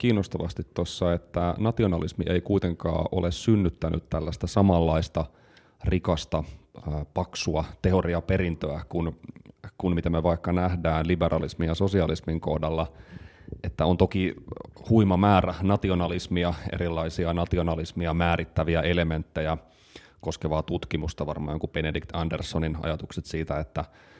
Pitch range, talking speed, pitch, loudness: 80-90 Hz, 105 wpm, 85 Hz, -27 LUFS